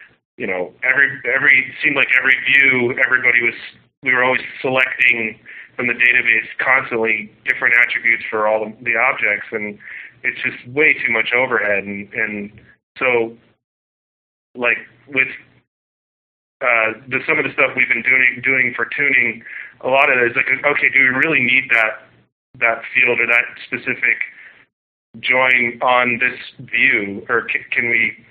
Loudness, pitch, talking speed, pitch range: -15 LUFS, 120 Hz, 155 wpm, 115-130 Hz